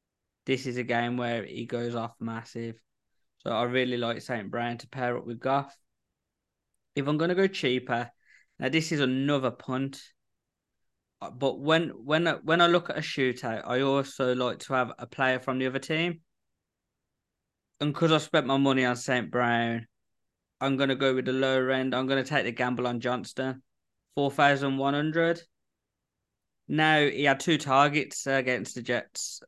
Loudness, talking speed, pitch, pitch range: -28 LUFS, 175 wpm, 130 Hz, 120-140 Hz